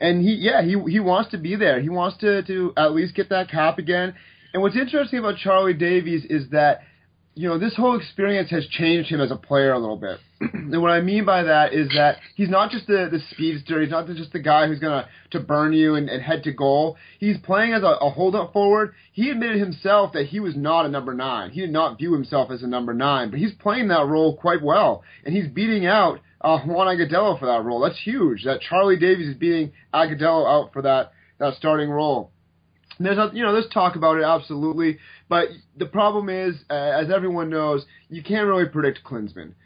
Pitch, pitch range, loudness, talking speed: 165 Hz, 150-195 Hz, -21 LUFS, 225 wpm